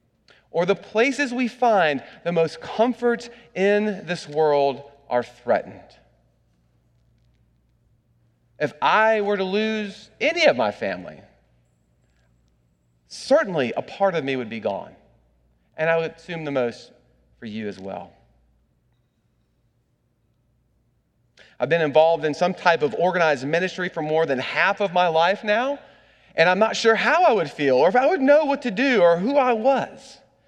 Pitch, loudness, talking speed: 165 Hz, -21 LUFS, 150 wpm